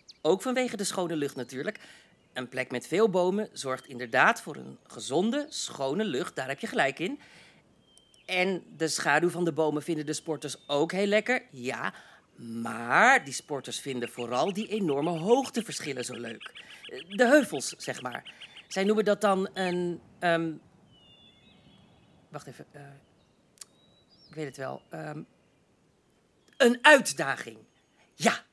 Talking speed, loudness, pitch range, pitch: 140 wpm, -28 LUFS, 135-210 Hz, 165 Hz